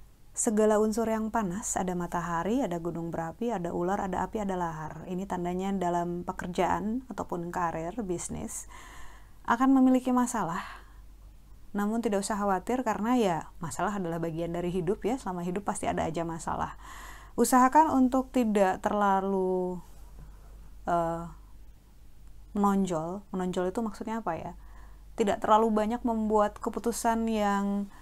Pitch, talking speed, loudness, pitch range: 195 Hz, 130 wpm, -29 LUFS, 175-225 Hz